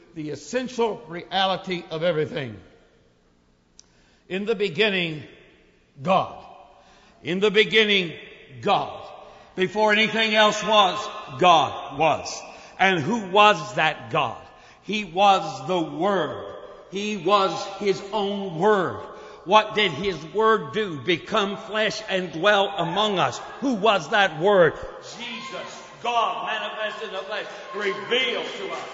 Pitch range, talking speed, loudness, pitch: 175-215 Hz, 115 wpm, -22 LUFS, 200 Hz